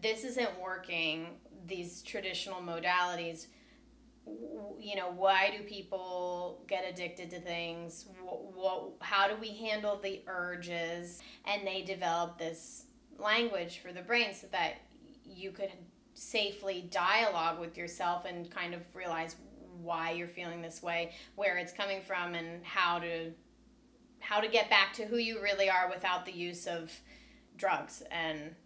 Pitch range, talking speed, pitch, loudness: 170-205 Hz, 145 wpm, 180 Hz, -35 LUFS